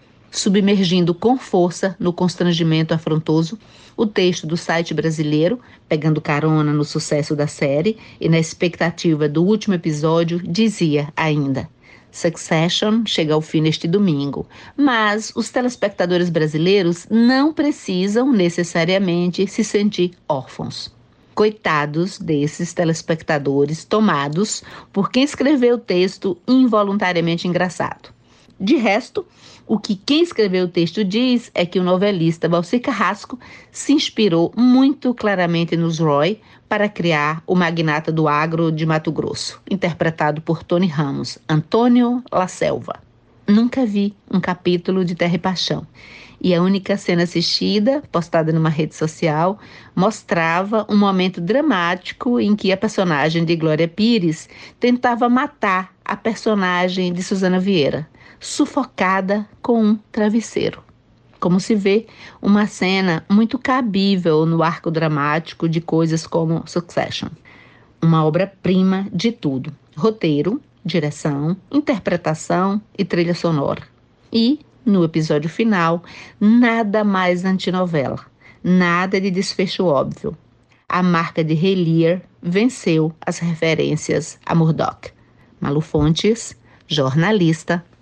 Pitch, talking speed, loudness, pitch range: 180 Hz, 120 wpm, -18 LUFS, 165-210 Hz